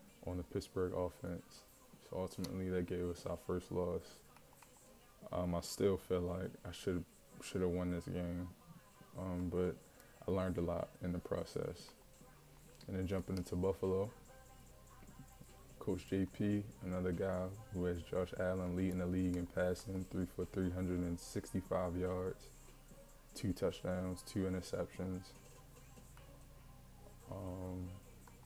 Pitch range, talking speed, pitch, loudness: 90-95 Hz, 125 wpm, 90 Hz, -42 LUFS